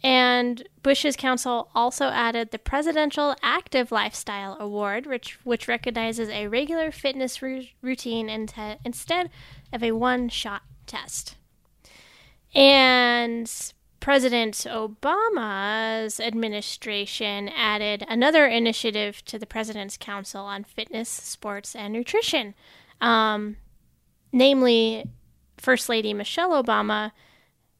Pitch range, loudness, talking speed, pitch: 215-260 Hz, -24 LUFS, 105 wpm, 230 Hz